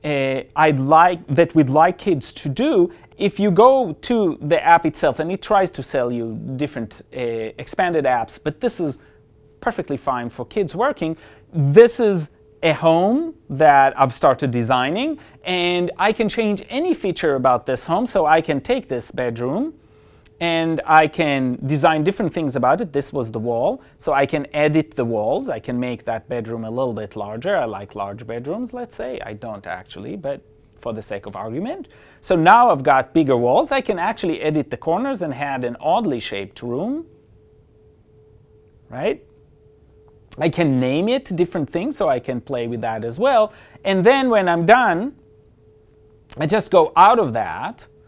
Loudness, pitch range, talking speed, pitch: -19 LUFS, 120-180 Hz, 180 wpm, 145 Hz